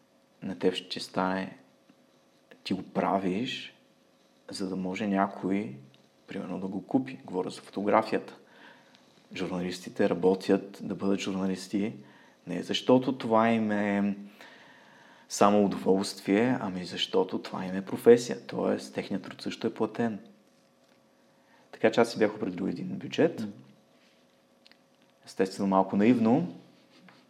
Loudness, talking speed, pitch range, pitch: -29 LUFS, 115 wpm, 95-105 Hz, 95 Hz